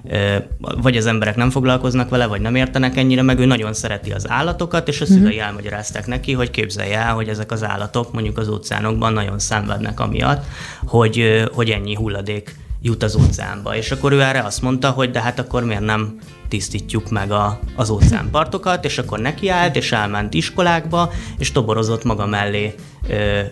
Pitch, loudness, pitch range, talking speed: 115 Hz, -18 LUFS, 105-130 Hz, 175 wpm